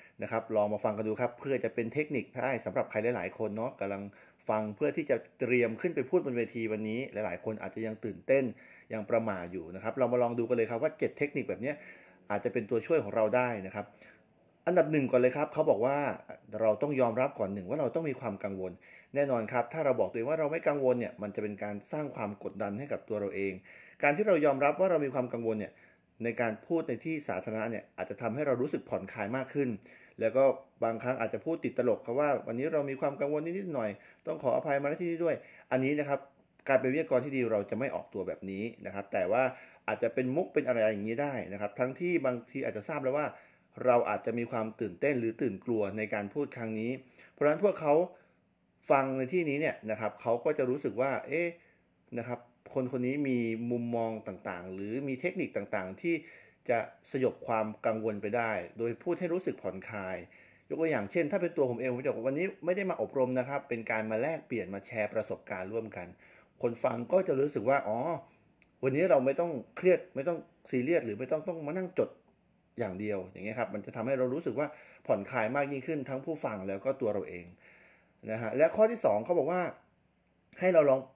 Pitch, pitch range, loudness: 120 Hz, 110-145 Hz, -32 LUFS